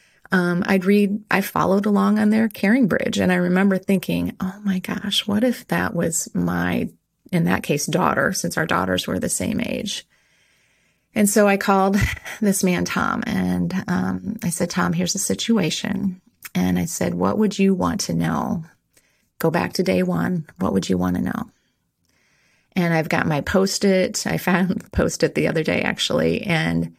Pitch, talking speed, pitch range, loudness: 190 Hz, 185 wpm, 160-205 Hz, -21 LUFS